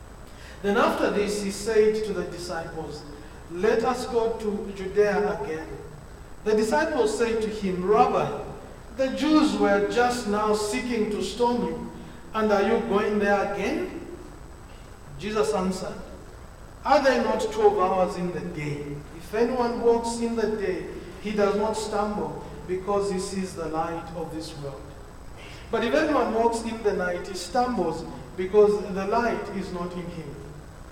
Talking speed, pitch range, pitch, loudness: 155 wpm, 180-230 Hz, 205 Hz, -25 LUFS